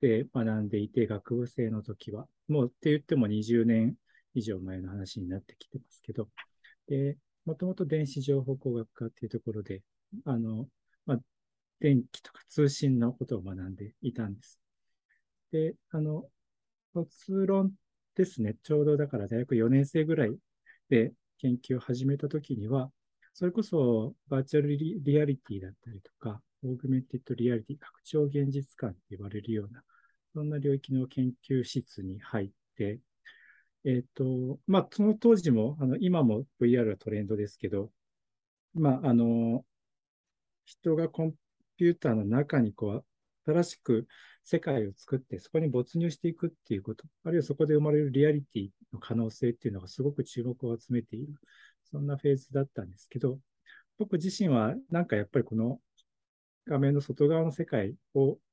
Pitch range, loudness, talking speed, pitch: 115-150 Hz, -31 LUFS, 320 characters per minute, 130 Hz